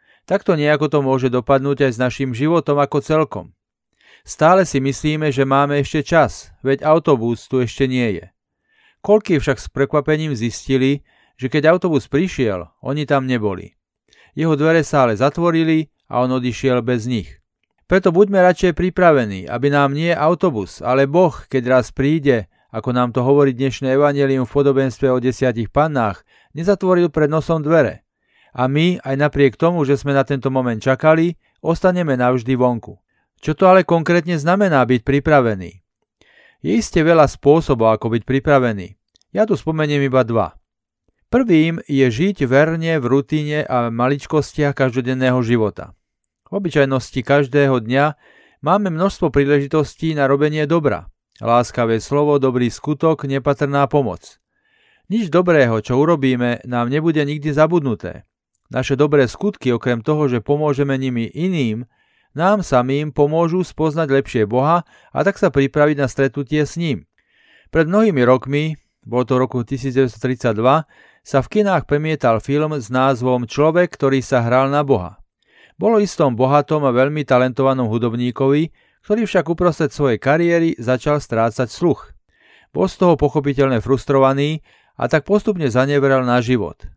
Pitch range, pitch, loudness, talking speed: 125-155 Hz, 140 Hz, -17 LUFS, 145 wpm